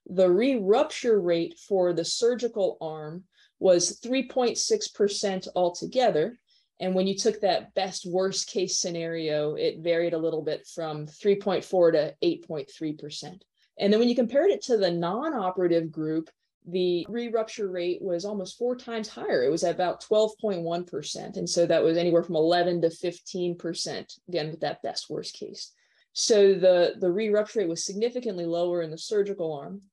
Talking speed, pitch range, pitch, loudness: 180 wpm, 170-215 Hz, 185 Hz, -26 LUFS